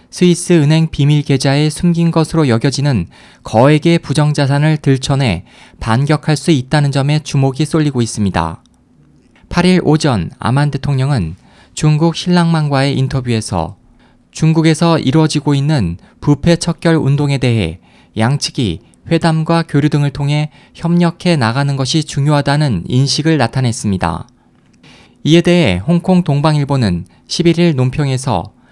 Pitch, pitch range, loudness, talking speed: 145 Hz, 125-160 Hz, -13 LUFS, 295 characters per minute